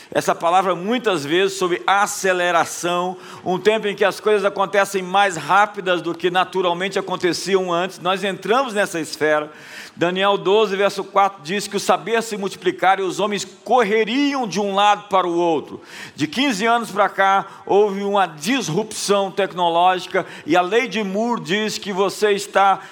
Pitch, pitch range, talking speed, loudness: 195 Hz, 185-210 Hz, 160 wpm, -19 LUFS